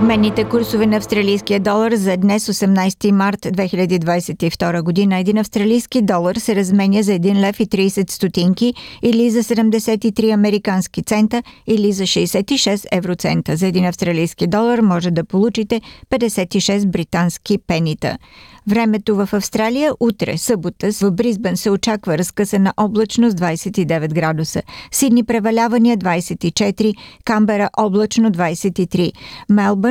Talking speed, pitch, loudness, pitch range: 125 wpm, 205 Hz, -16 LUFS, 185-220 Hz